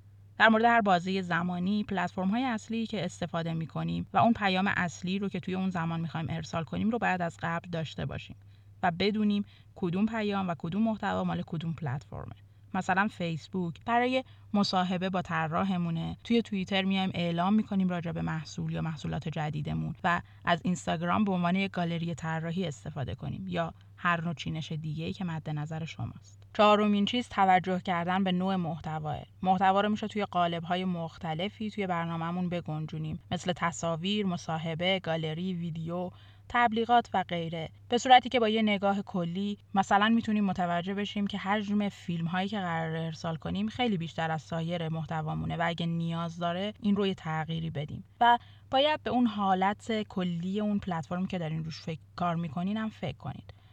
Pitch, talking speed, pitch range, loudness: 175 Hz, 170 wpm, 160-200 Hz, -30 LUFS